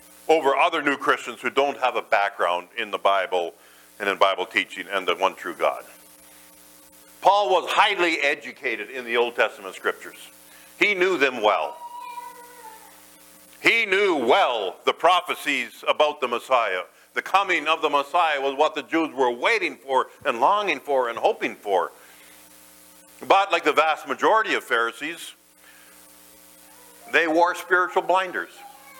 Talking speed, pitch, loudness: 145 wpm, 135 Hz, -22 LUFS